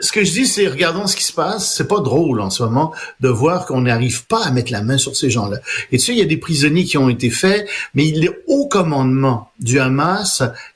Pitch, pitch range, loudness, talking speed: 145 Hz, 130-190 Hz, -16 LUFS, 260 wpm